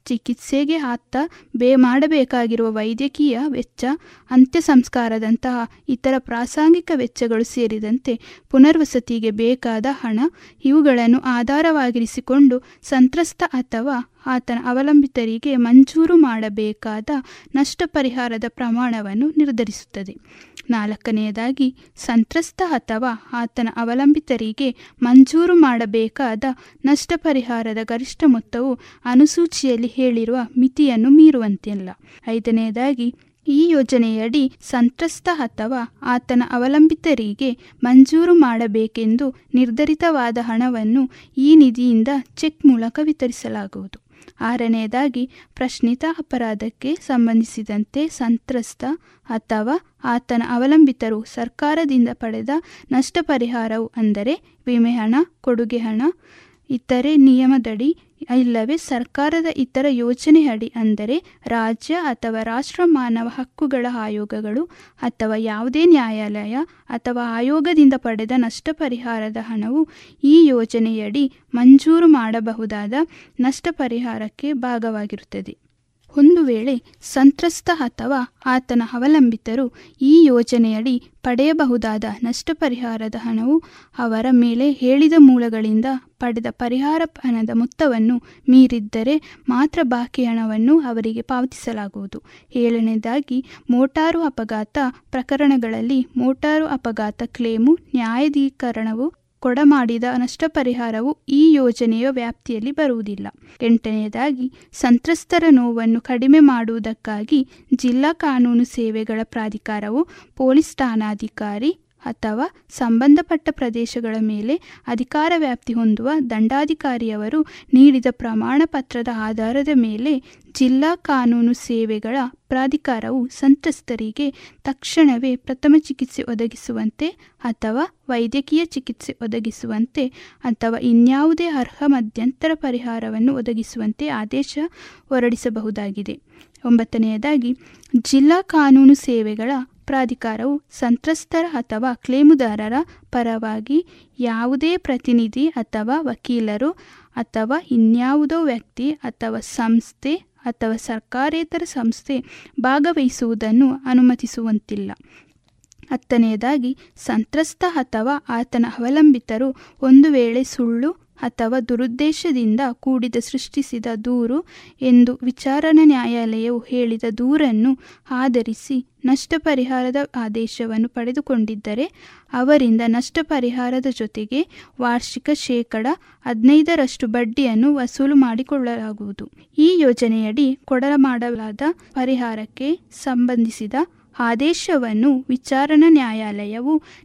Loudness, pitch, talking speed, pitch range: -18 LUFS, 255 Hz, 80 wpm, 230-285 Hz